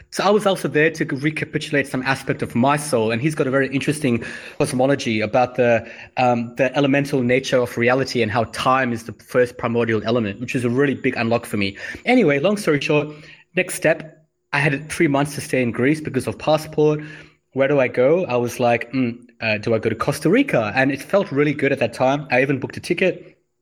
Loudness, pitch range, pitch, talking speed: -20 LUFS, 120-150 Hz, 135 Hz, 225 wpm